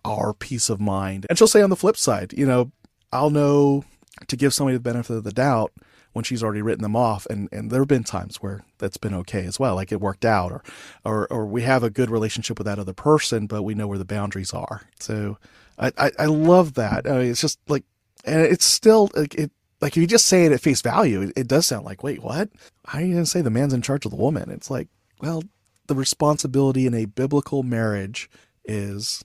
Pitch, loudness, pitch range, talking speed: 125 Hz, -21 LUFS, 105-145 Hz, 240 wpm